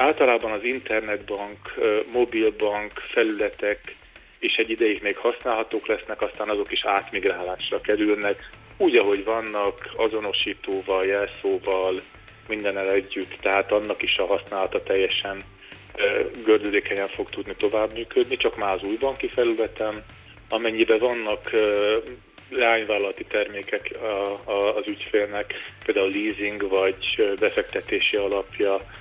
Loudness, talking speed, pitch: -24 LUFS, 105 wpm, 115 Hz